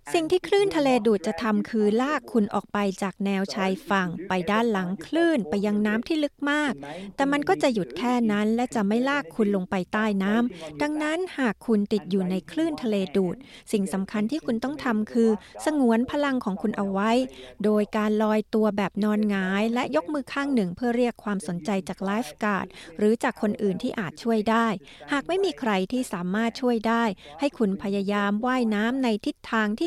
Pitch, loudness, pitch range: 220 Hz, -25 LUFS, 200-255 Hz